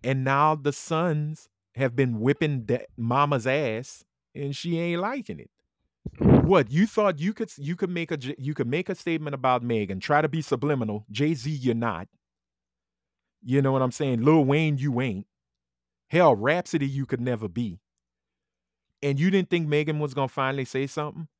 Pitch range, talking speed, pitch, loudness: 120-155 Hz, 180 wpm, 140 Hz, -25 LUFS